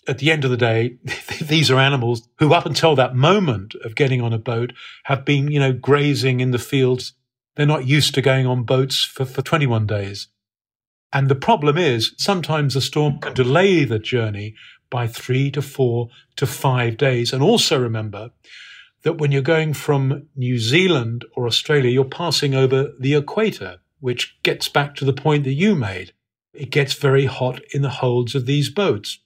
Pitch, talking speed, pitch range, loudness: 135 Hz, 190 wpm, 120-145 Hz, -19 LUFS